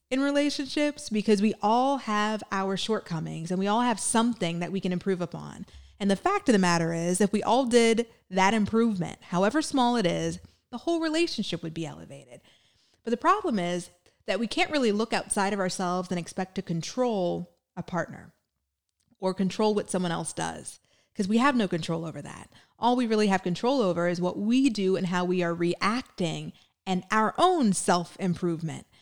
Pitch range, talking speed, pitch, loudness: 175-235 Hz, 190 wpm, 195 Hz, -27 LUFS